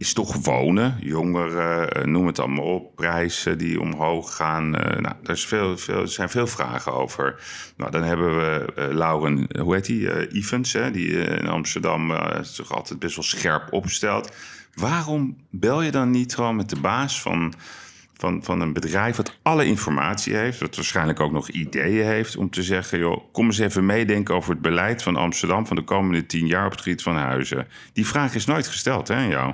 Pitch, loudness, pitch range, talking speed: 90 Hz, -23 LUFS, 80-110 Hz, 195 wpm